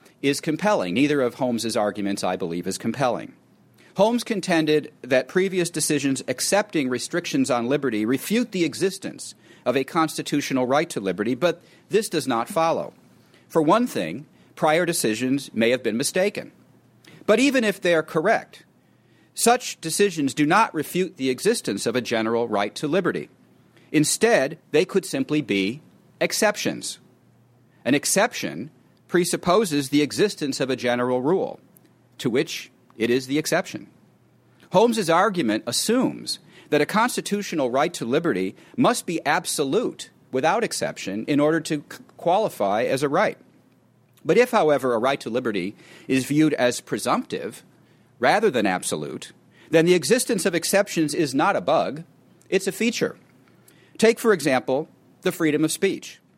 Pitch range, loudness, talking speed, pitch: 135-195 Hz, -23 LUFS, 145 wpm, 160 Hz